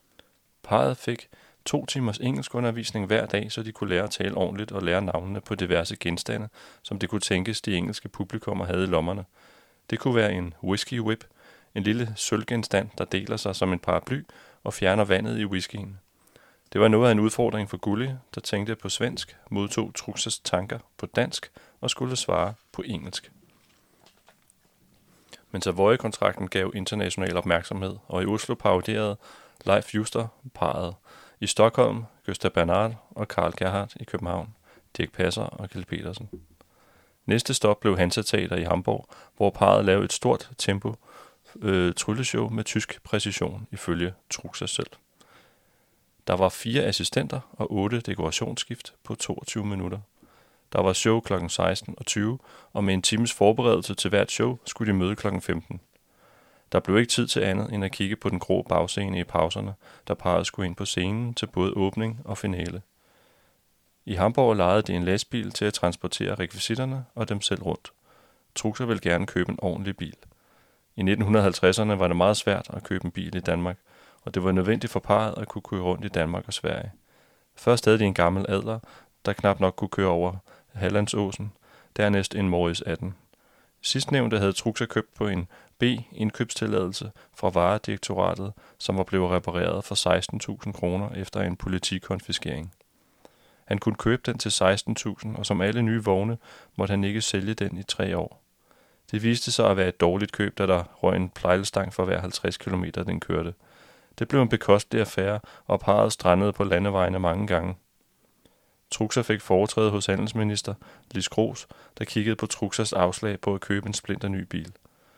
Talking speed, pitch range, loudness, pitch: 170 wpm, 95-110 Hz, -26 LUFS, 100 Hz